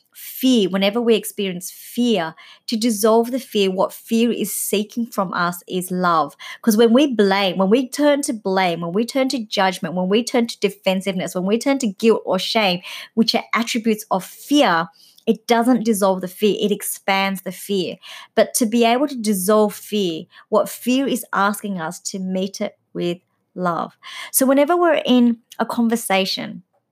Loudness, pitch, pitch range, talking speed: -19 LUFS, 210 Hz, 190-235 Hz, 180 wpm